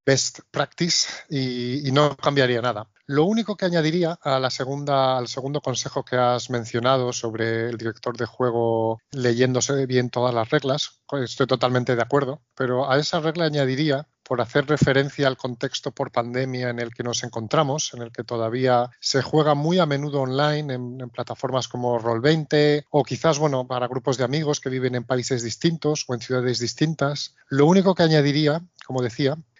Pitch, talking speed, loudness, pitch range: 130 Hz, 180 wpm, -23 LUFS, 125-150 Hz